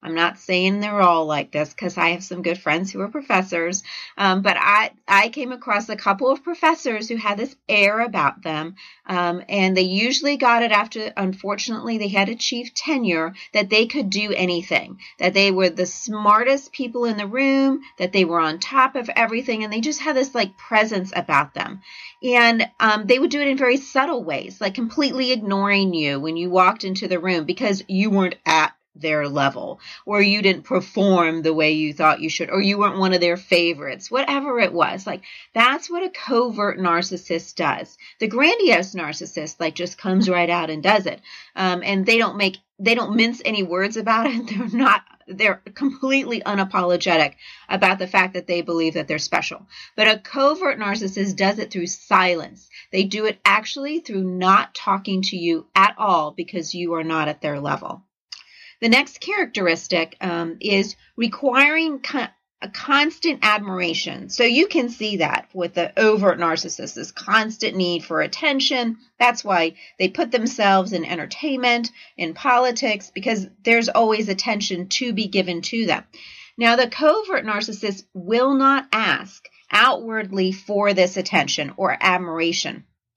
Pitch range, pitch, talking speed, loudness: 180-235 Hz, 200 Hz, 175 wpm, -20 LUFS